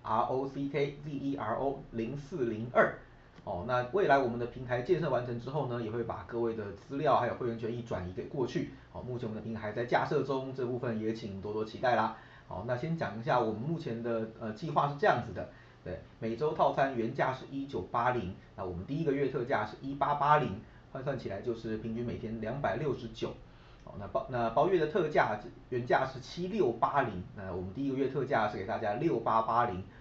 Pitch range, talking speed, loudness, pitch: 110-140 Hz, 330 characters per minute, -33 LUFS, 120 Hz